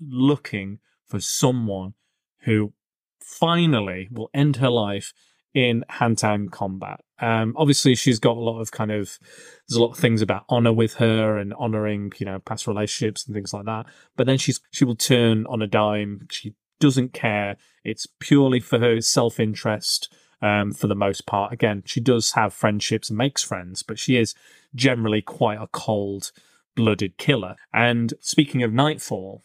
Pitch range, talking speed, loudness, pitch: 105-125 Hz, 165 wpm, -22 LUFS, 115 Hz